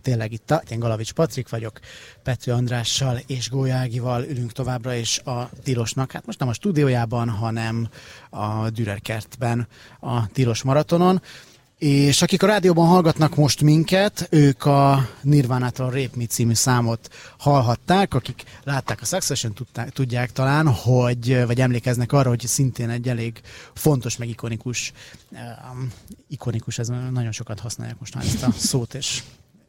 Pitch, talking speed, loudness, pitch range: 125 Hz, 145 wpm, -21 LUFS, 120-140 Hz